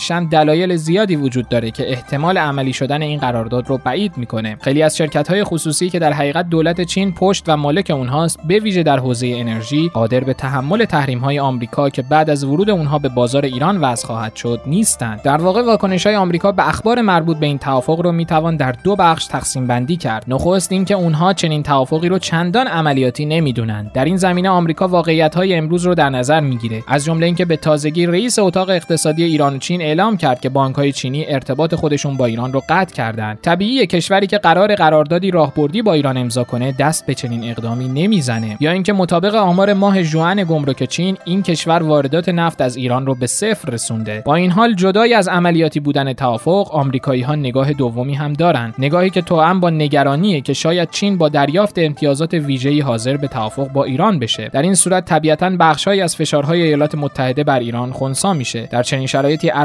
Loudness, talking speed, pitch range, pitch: -15 LUFS, 195 wpm, 135-175 Hz, 155 Hz